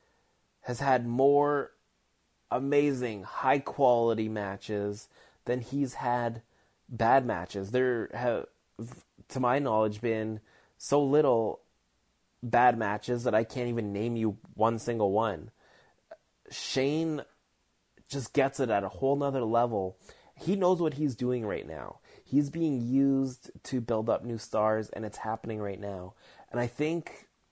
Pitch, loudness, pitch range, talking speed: 120 Hz, -30 LUFS, 110-135 Hz, 135 wpm